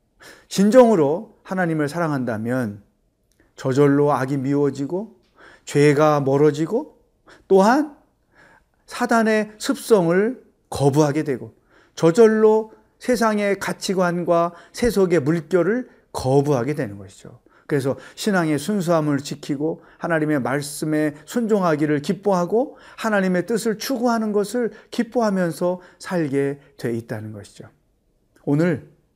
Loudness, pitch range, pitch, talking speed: -20 LUFS, 145-215 Hz, 170 Hz, 255 characters per minute